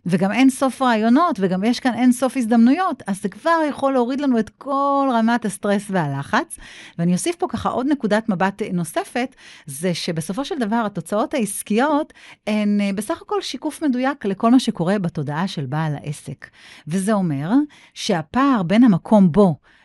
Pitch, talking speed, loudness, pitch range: 220 Hz, 160 wpm, -20 LUFS, 190-265 Hz